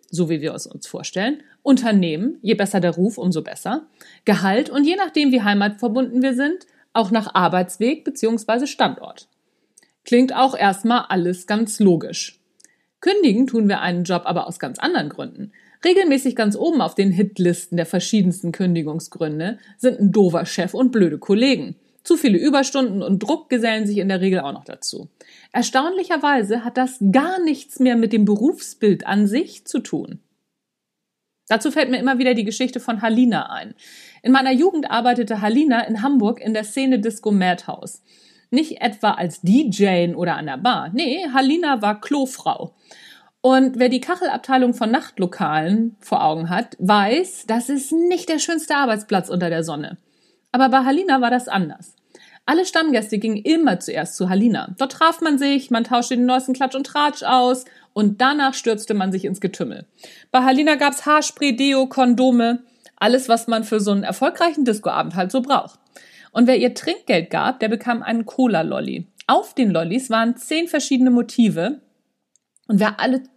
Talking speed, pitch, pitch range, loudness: 170 wpm, 240 Hz, 205-270 Hz, -19 LUFS